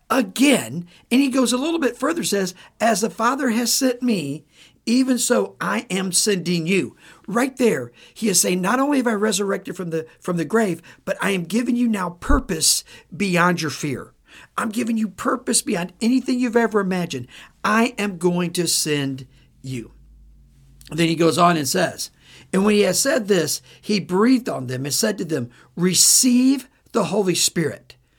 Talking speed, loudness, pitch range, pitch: 185 wpm, -20 LUFS, 165-235 Hz, 195 Hz